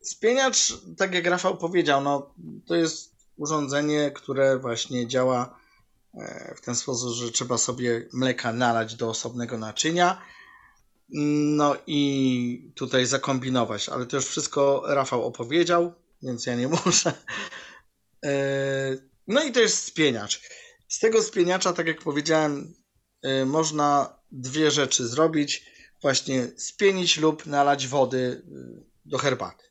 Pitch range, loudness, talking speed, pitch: 125-160 Hz, -24 LUFS, 120 wpm, 140 Hz